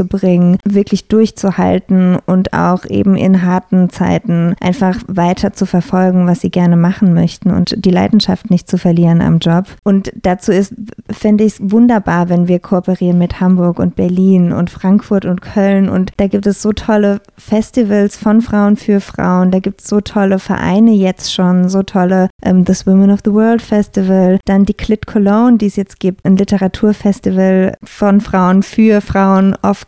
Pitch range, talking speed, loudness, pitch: 185-205 Hz, 175 wpm, -12 LUFS, 195 Hz